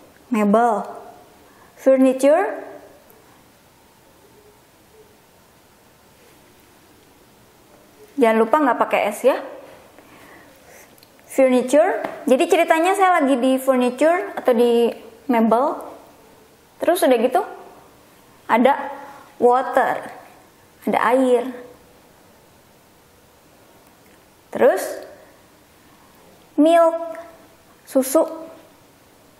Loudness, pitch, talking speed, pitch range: -18 LUFS, 275 Hz, 55 wpm, 245-325 Hz